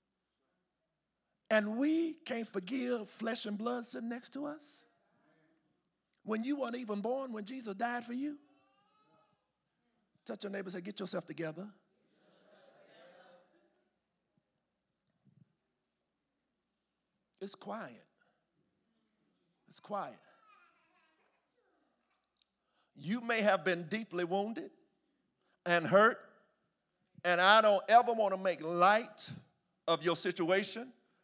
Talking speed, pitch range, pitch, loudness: 100 wpm, 190-240 Hz, 210 Hz, -33 LUFS